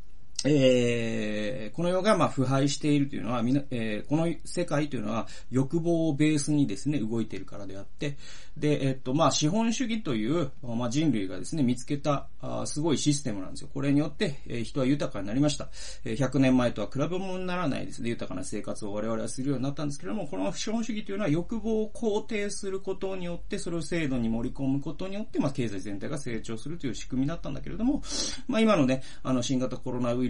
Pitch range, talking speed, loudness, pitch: 120-170 Hz, 445 characters per minute, -29 LUFS, 140 Hz